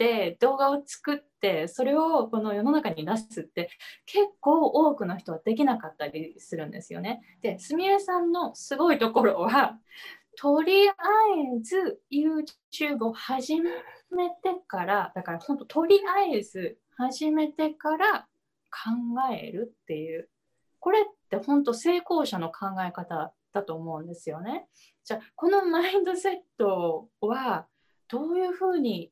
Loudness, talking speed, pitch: -27 LUFS, 280 characters per minute, 285 Hz